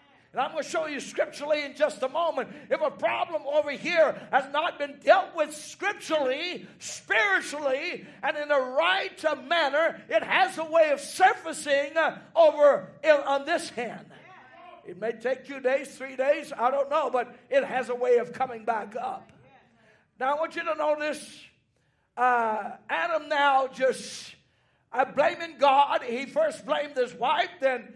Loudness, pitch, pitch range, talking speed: -26 LUFS, 290 Hz, 260-320 Hz, 170 wpm